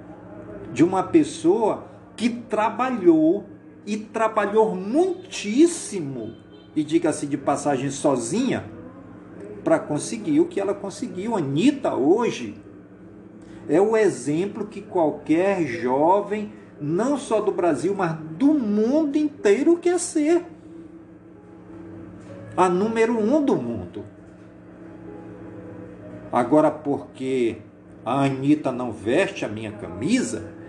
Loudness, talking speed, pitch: -22 LUFS, 100 wpm, 205 Hz